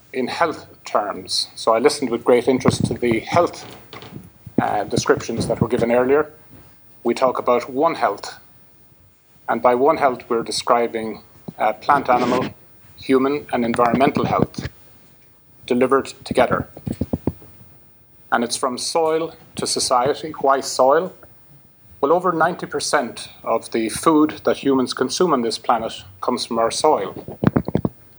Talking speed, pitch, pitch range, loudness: 130 wpm, 125 Hz, 115-140 Hz, -20 LUFS